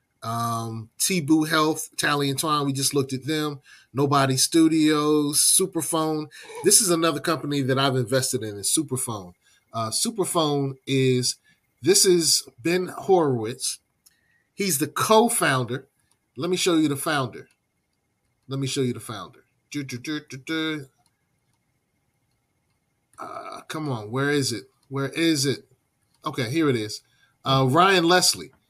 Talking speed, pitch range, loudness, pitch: 135 wpm, 130-160 Hz, -22 LUFS, 140 Hz